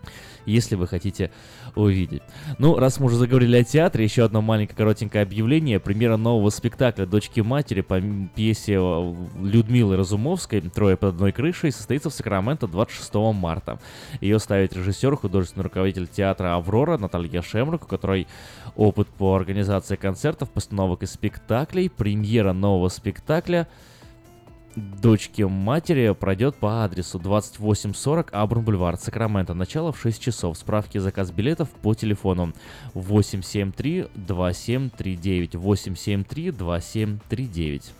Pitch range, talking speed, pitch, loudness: 95-120 Hz, 120 wpm, 105 Hz, -23 LUFS